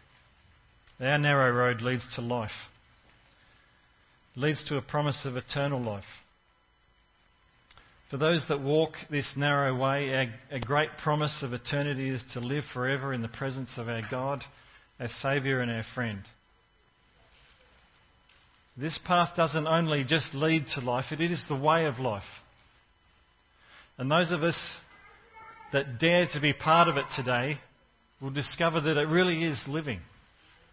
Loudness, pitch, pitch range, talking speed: -29 LUFS, 135 Hz, 125-155 Hz, 145 wpm